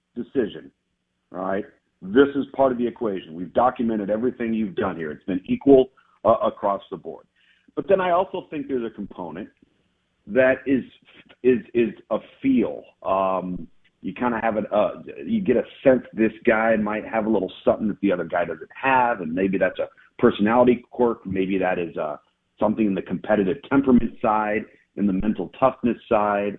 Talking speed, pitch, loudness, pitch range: 180 wpm, 110 Hz, -23 LUFS, 95-130 Hz